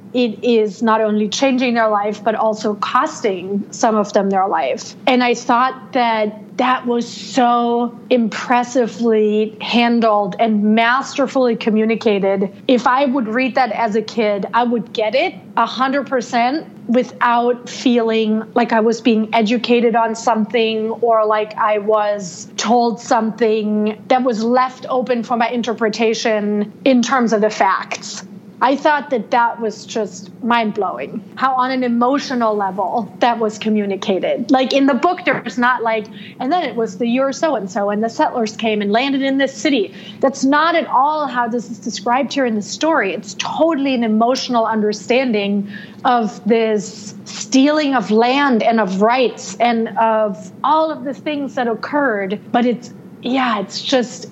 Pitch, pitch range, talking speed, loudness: 230 Hz, 215-250 Hz, 160 wpm, -17 LUFS